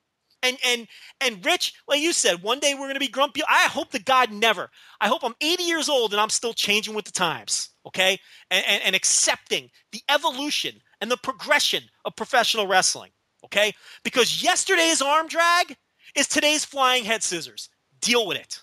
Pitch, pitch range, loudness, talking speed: 250 Hz, 210-295 Hz, -22 LUFS, 185 wpm